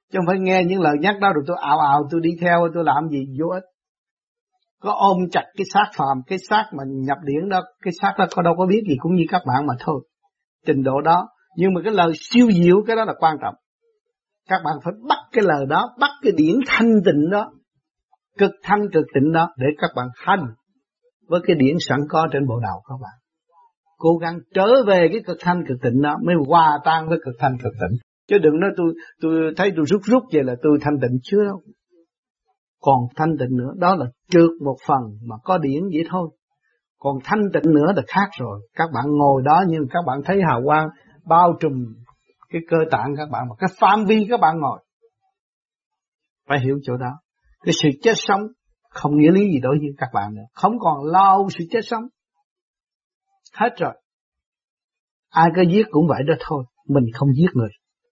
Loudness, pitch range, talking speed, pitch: -19 LUFS, 145-200 Hz, 215 wpm, 170 Hz